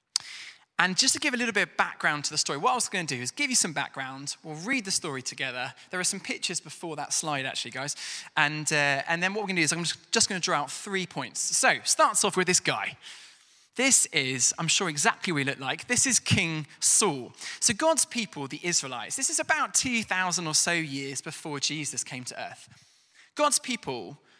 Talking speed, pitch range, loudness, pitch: 225 wpm, 145-220 Hz, -26 LUFS, 170 Hz